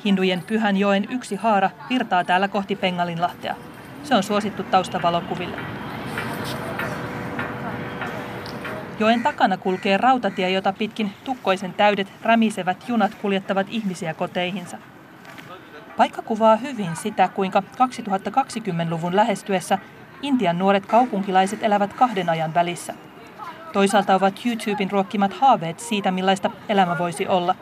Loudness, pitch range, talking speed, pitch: -22 LUFS, 185-215 Hz, 110 wpm, 195 Hz